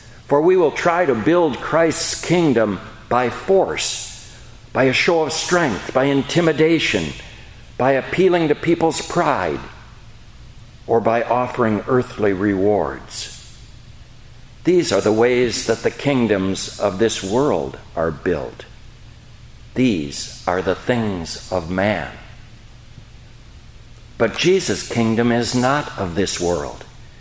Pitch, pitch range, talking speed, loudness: 120 Hz, 115-130 Hz, 115 wpm, -19 LUFS